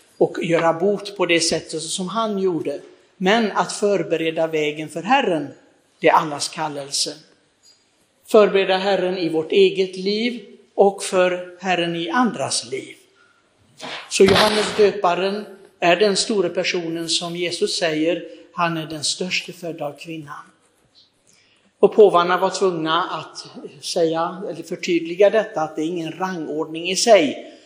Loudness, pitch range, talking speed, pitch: -19 LUFS, 165-205 Hz, 140 wpm, 180 Hz